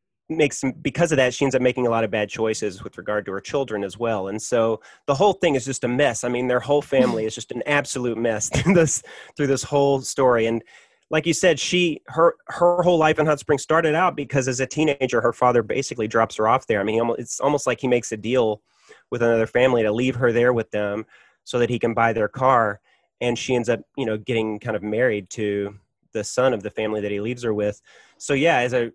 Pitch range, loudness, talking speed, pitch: 110-140 Hz, -21 LUFS, 250 wpm, 120 Hz